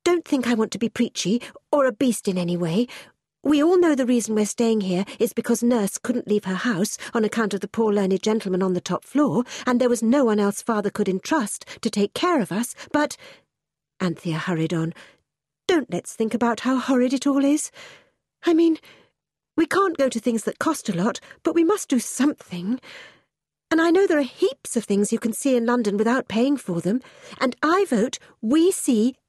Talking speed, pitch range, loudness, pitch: 215 wpm, 210-285 Hz, -22 LUFS, 240 Hz